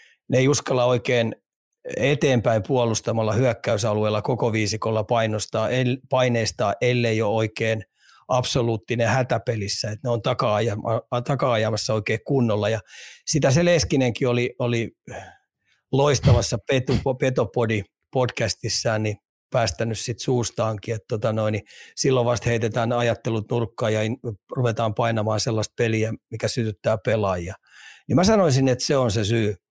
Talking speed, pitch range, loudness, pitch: 120 wpm, 110-125 Hz, -23 LUFS, 115 Hz